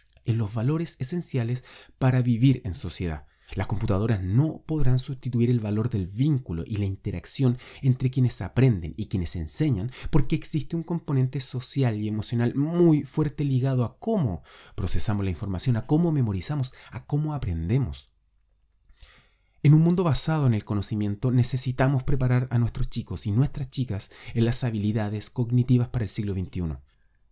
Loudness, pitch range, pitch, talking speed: -24 LUFS, 100-135 Hz, 120 Hz, 155 wpm